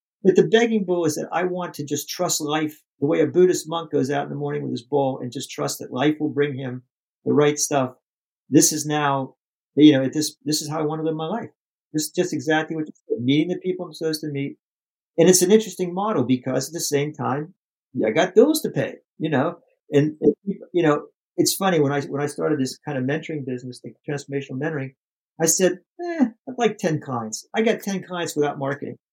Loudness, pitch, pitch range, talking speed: -22 LUFS, 155 Hz, 140-180 Hz, 235 wpm